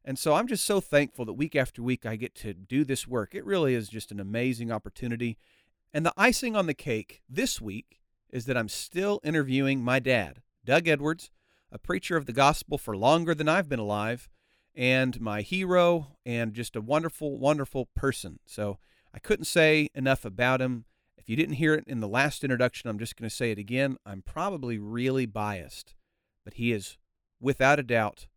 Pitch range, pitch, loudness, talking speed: 110-150 Hz, 125 Hz, -28 LUFS, 195 wpm